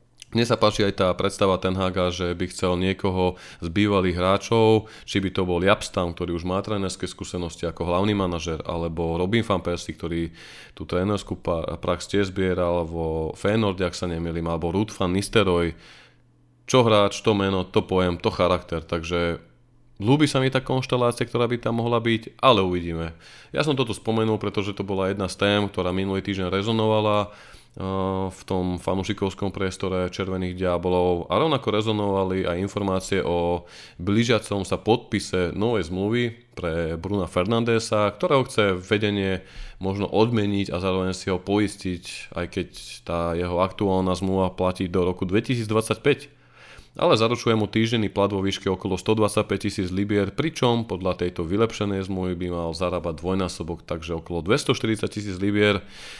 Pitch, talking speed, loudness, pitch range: 95 Hz, 155 wpm, -24 LUFS, 90-105 Hz